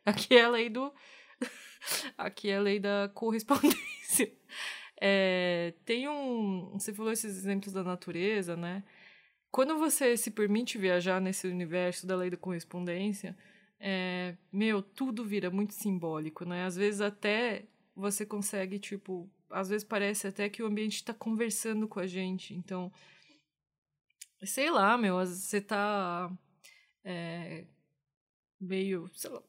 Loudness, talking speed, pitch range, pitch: -32 LUFS, 135 wpm, 180-215 Hz, 200 Hz